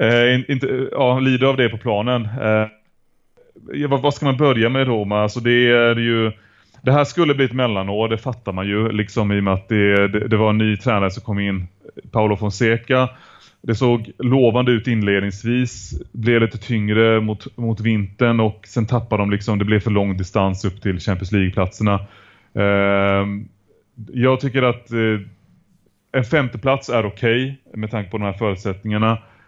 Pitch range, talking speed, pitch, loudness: 100-125 Hz, 185 wpm, 110 Hz, -19 LUFS